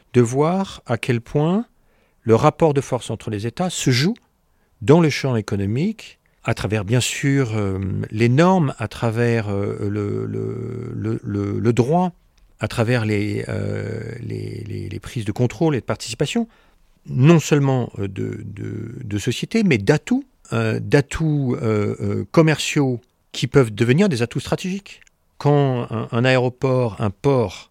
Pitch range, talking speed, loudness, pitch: 110-145 Hz, 150 wpm, -20 LUFS, 120 Hz